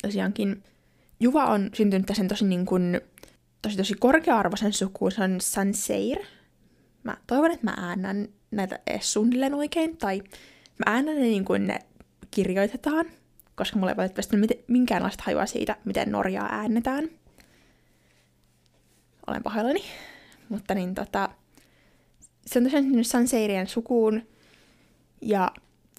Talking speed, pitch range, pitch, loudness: 120 wpm, 195-250 Hz, 215 Hz, -26 LUFS